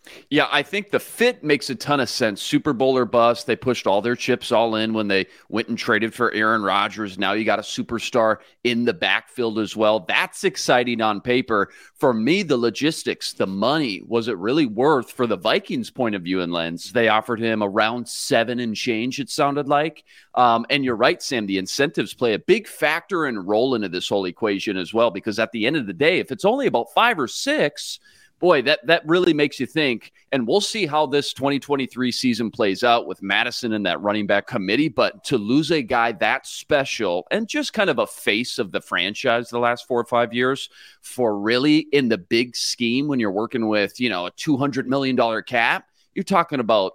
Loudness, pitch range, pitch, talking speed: -21 LUFS, 110-140 Hz, 120 Hz, 215 wpm